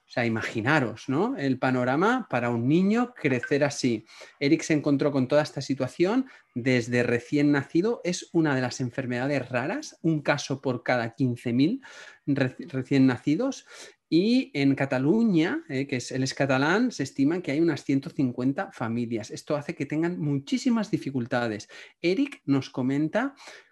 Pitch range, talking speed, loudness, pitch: 130-165 Hz, 150 wpm, -26 LUFS, 140 Hz